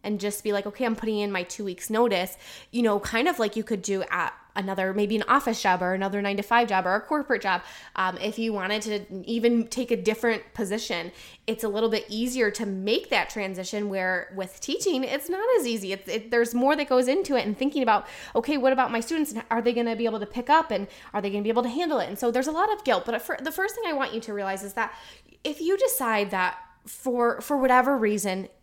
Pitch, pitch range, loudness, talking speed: 225 Hz, 200-255 Hz, -26 LUFS, 260 wpm